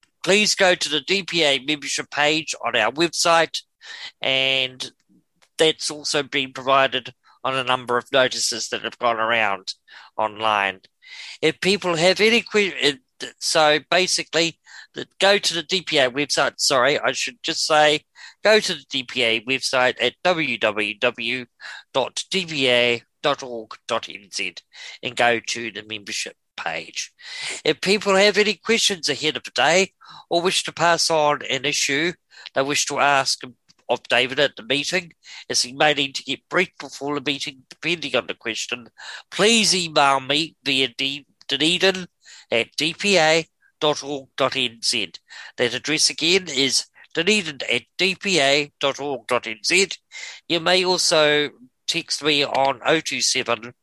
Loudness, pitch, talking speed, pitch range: -20 LUFS, 150 Hz, 130 wpm, 130-170 Hz